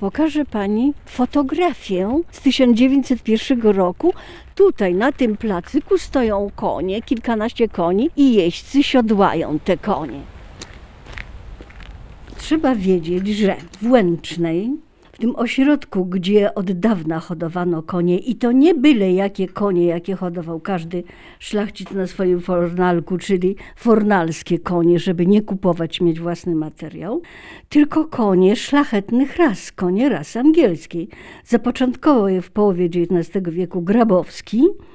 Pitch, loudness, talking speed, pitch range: 200 Hz, -18 LUFS, 115 wpm, 180-255 Hz